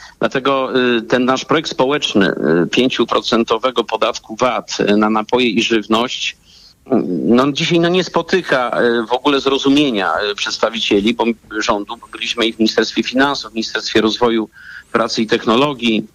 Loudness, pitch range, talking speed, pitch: -16 LUFS, 110-135 Hz, 125 wpm, 120 Hz